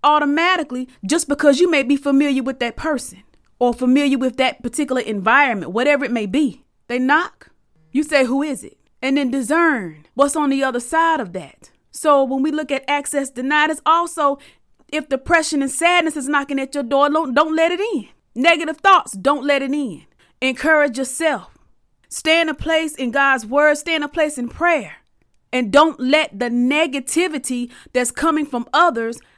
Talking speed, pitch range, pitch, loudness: 185 wpm, 260-310 Hz, 285 Hz, -18 LUFS